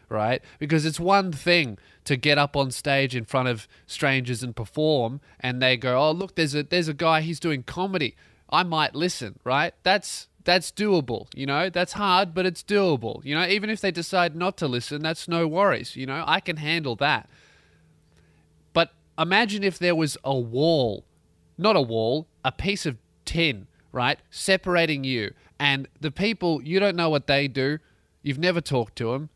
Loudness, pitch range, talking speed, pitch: -24 LUFS, 130-175 Hz, 190 wpm, 155 Hz